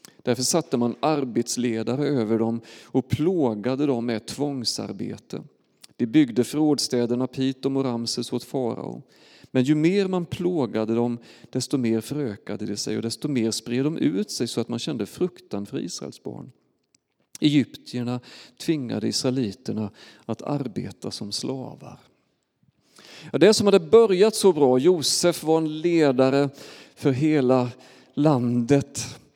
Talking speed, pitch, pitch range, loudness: 135 wpm, 130 Hz, 120-150 Hz, -24 LUFS